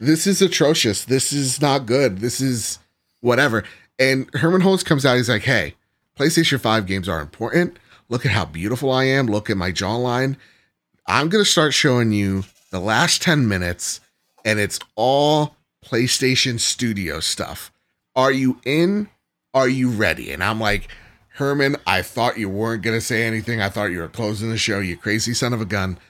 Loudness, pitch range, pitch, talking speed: -19 LUFS, 105-135 Hz, 120 Hz, 185 wpm